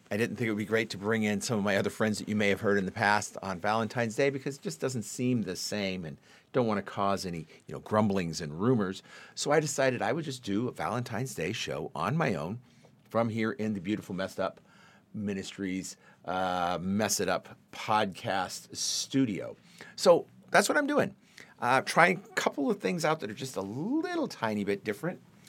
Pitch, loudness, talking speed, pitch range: 110 Hz, -30 LUFS, 215 wpm, 100-135 Hz